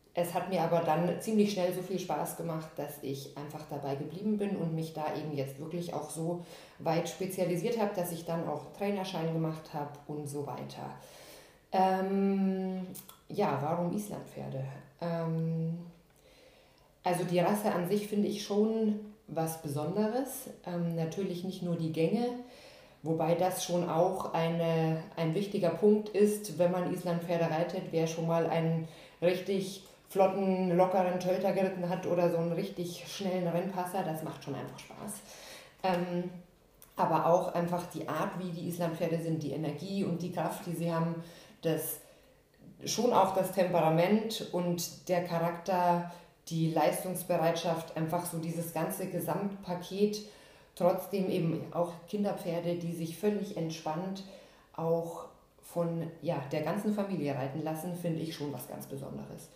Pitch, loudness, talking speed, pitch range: 175 Hz, -33 LUFS, 150 wpm, 165-190 Hz